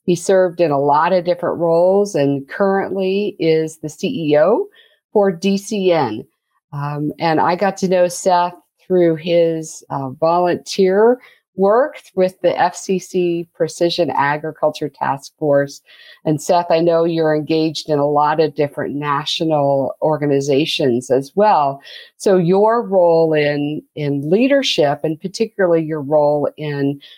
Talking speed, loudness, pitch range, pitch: 130 wpm, -17 LUFS, 150-185 Hz, 165 Hz